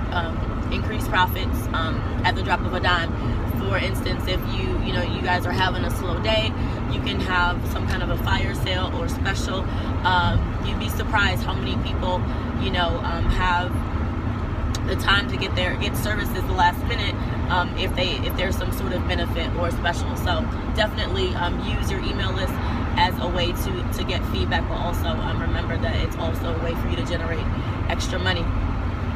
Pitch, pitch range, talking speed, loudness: 95 Hz, 85-110 Hz, 195 wpm, -24 LUFS